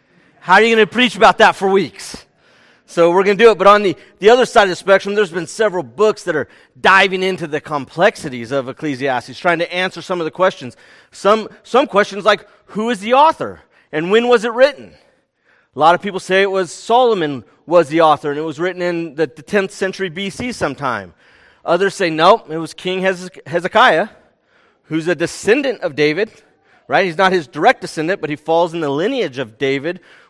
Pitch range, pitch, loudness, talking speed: 160-210 Hz, 185 Hz, -15 LUFS, 210 wpm